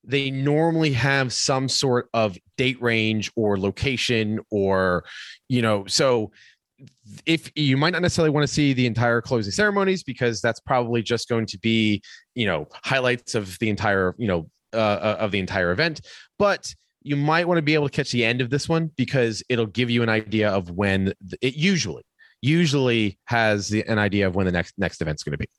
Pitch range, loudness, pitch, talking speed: 105-140 Hz, -22 LUFS, 120 Hz, 195 wpm